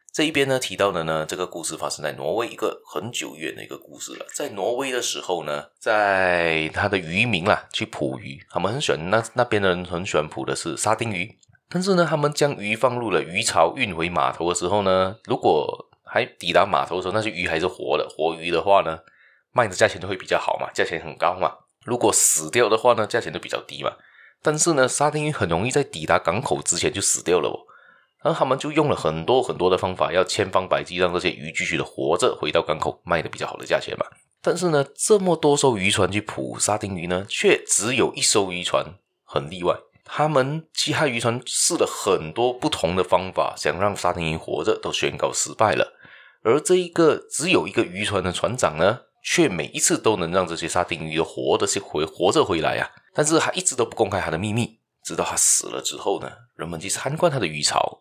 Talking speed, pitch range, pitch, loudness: 325 characters per minute, 90-145 Hz, 105 Hz, -22 LUFS